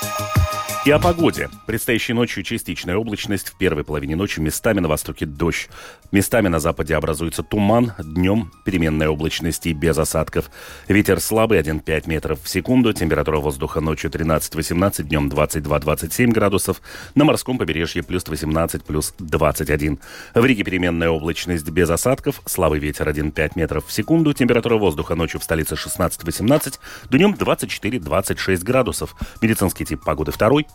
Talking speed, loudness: 140 wpm, -20 LUFS